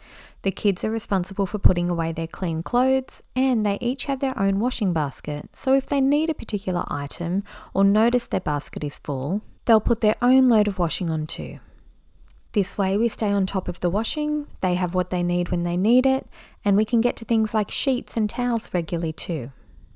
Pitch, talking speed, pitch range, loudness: 200 Hz, 210 wpm, 175-235 Hz, -23 LUFS